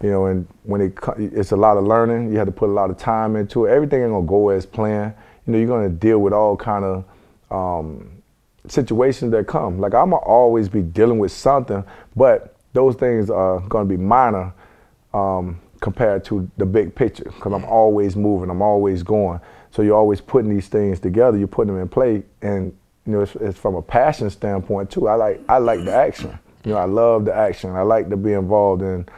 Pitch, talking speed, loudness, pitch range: 105 Hz, 220 wpm, -18 LUFS, 95-110 Hz